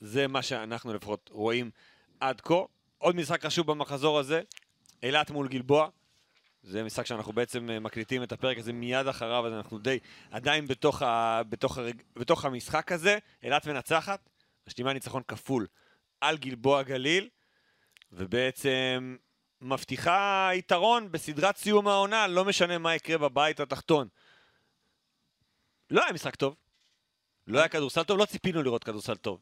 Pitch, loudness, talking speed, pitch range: 135 Hz, -29 LUFS, 140 wpm, 120-165 Hz